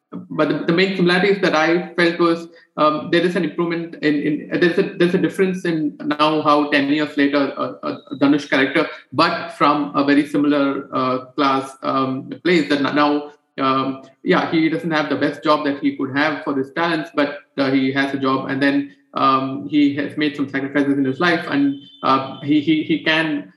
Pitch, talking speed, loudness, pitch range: 145 Hz, 200 wpm, -19 LUFS, 140-165 Hz